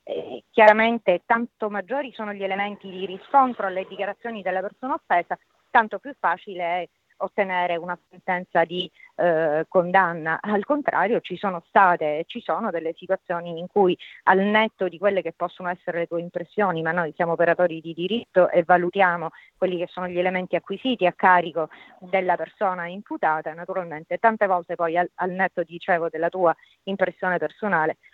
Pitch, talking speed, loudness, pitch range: 180 Hz, 165 wpm, -23 LUFS, 170-200 Hz